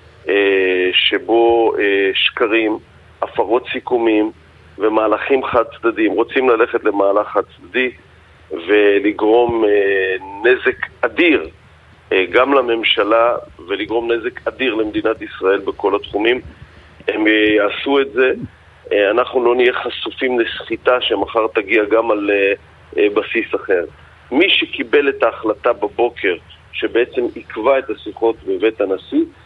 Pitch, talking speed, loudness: 120 Hz, 100 wpm, -16 LUFS